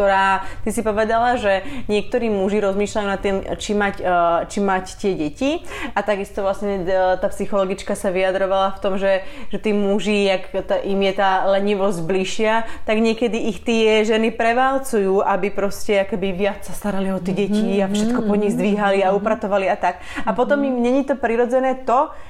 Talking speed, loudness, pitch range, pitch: 165 wpm, -20 LUFS, 195-225 Hz, 205 Hz